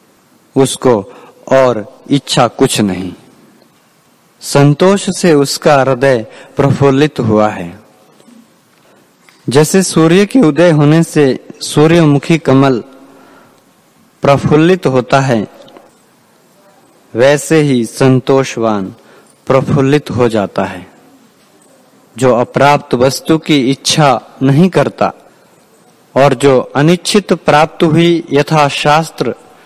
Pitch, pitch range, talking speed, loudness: 140 Hz, 130-160 Hz, 90 wpm, -10 LUFS